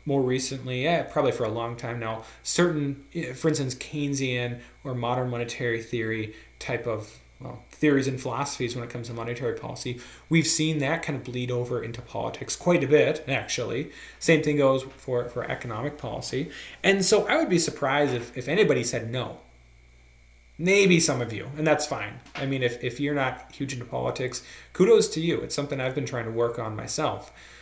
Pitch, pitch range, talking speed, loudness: 130 Hz, 120-145 Hz, 190 wpm, -26 LUFS